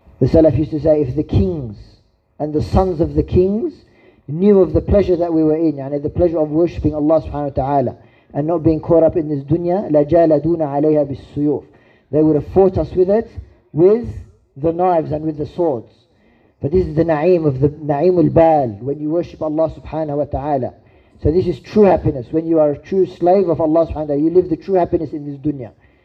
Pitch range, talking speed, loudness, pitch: 140-170 Hz, 215 wpm, -16 LUFS, 155 Hz